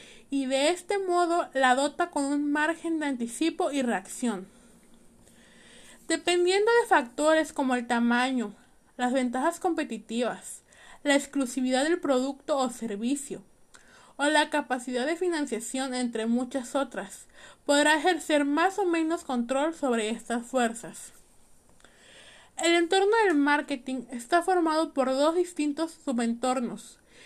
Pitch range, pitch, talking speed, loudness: 250-325 Hz, 275 Hz, 120 wpm, -27 LUFS